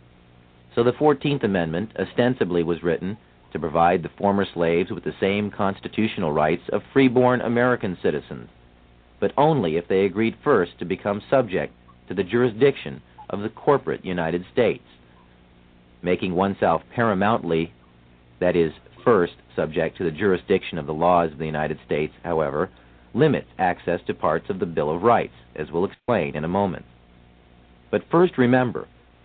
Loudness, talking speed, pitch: -23 LUFS, 150 wpm, 85 Hz